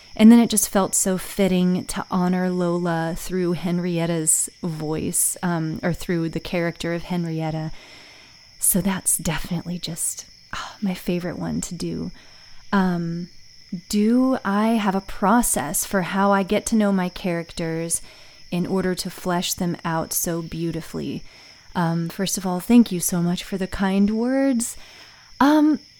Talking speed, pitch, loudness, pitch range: 150 wpm, 180 Hz, -22 LUFS, 170-195 Hz